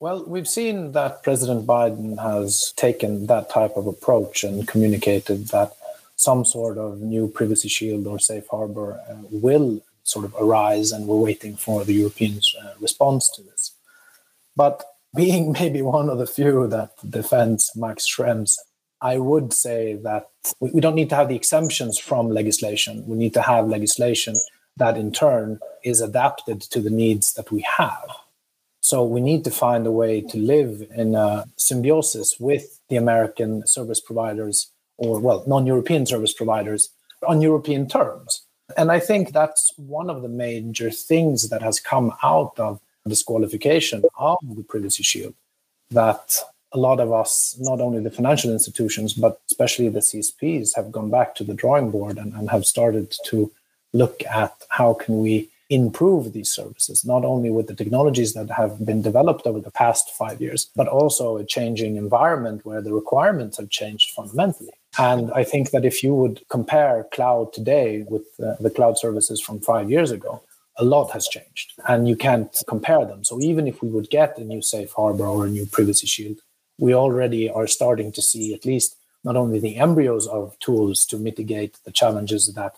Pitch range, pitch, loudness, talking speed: 110-130 Hz, 115 Hz, -20 LUFS, 180 wpm